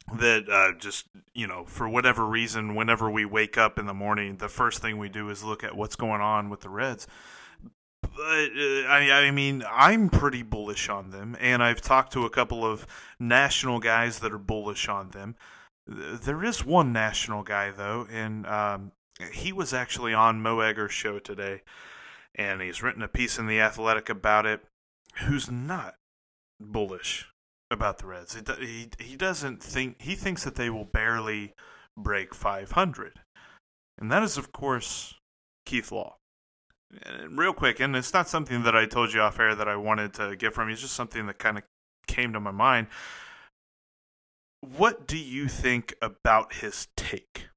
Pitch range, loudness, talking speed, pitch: 105-125 Hz, -26 LUFS, 175 wpm, 115 Hz